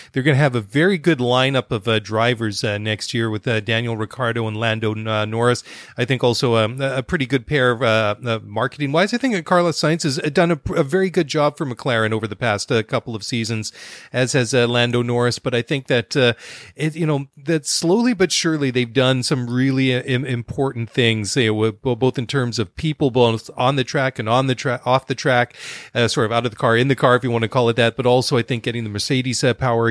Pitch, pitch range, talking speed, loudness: 125 Hz, 115-140 Hz, 245 wpm, -19 LUFS